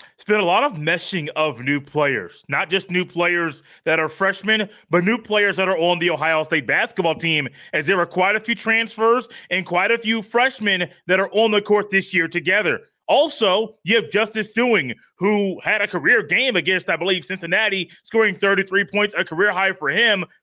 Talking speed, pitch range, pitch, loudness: 205 wpm, 175-215 Hz, 190 Hz, -19 LUFS